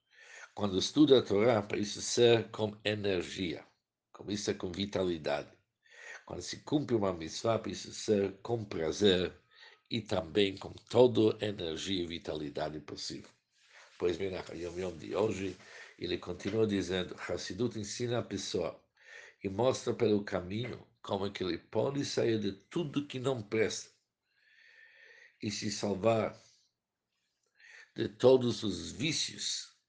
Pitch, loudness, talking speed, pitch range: 105 Hz, -33 LUFS, 130 wpm, 95-120 Hz